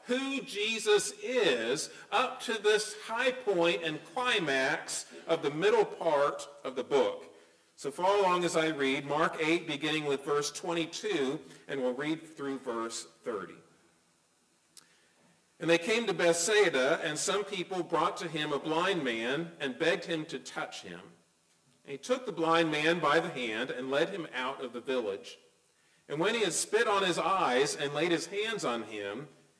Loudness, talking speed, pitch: -31 LUFS, 170 wpm, 160 Hz